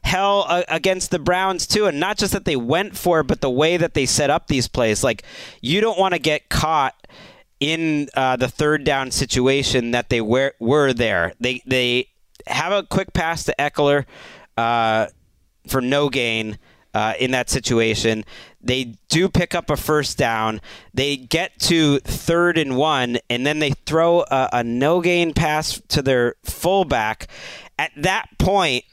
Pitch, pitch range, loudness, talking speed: 140 Hz, 125-165 Hz, -19 LUFS, 175 wpm